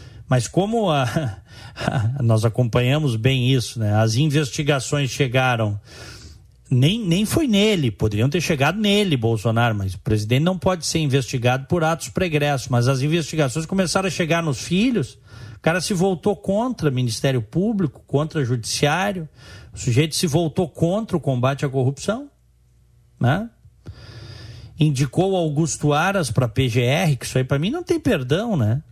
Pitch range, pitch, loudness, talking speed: 120-170 Hz, 140 Hz, -20 LUFS, 150 wpm